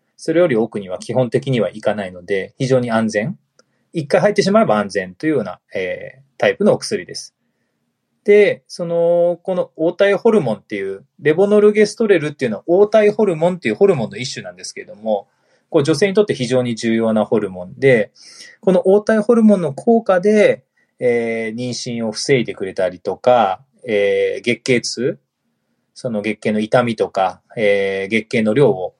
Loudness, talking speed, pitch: -17 LUFS, 355 characters per minute, 150 Hz